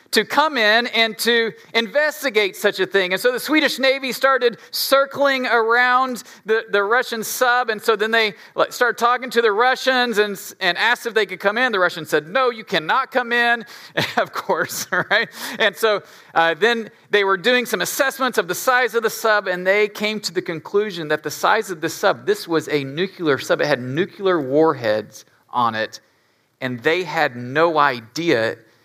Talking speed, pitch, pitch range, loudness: 195 wpm, 215 Hz, 180-245 Hz, -19 LUFS